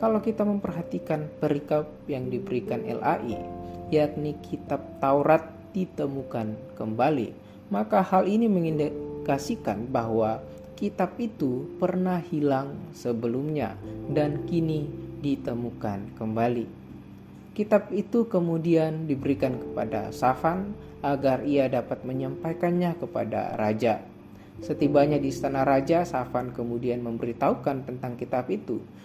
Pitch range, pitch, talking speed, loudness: 120-165 Hz, 140 Hz, 100 wpm, -27 LUFS